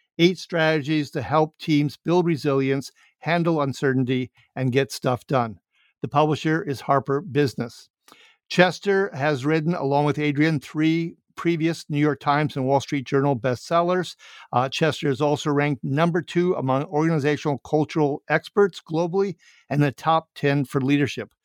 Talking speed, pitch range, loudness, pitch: 145 wpm, 140-160 Hz, -23 LUFS, 150 Hz